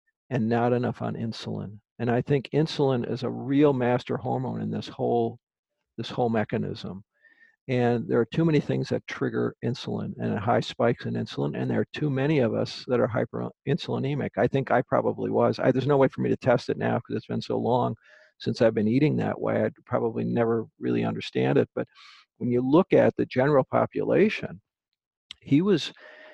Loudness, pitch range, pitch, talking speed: -26 LUFS, 115-145 Hz, 120 Hz, 195 wpm